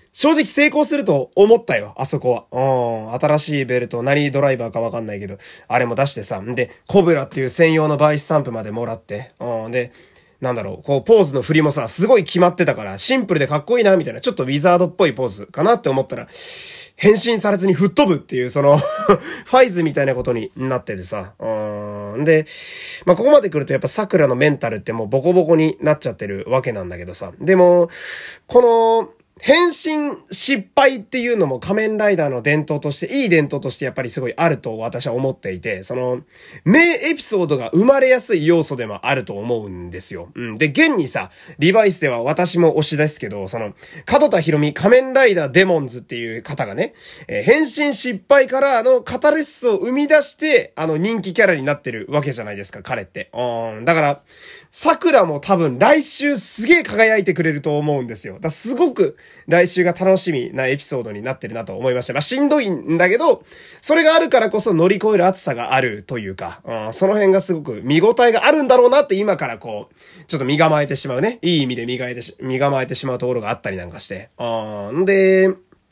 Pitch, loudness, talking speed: 160 Hz, -17 LUFS, 425 characters per minute